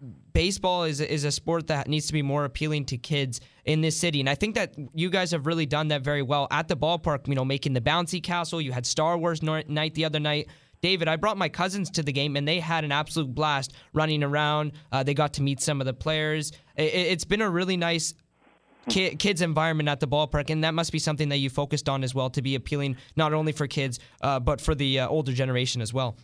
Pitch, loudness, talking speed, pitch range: 150 Hz, -26 LUFS, 250 wpm, 140-160 Hz